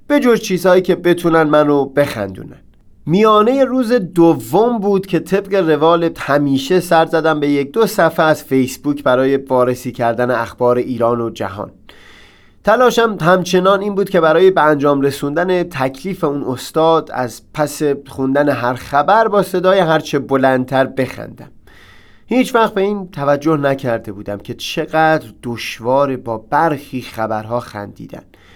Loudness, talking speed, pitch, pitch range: -15 LUFS, 140 wpm, 145 Hz, 125-180 Hz